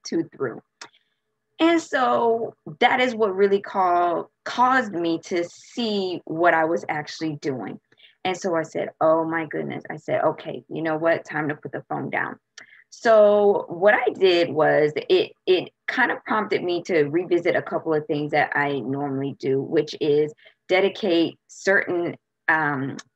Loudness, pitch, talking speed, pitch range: -22 LUFS, 175 Hz, 165 wpm, 155-210 Hz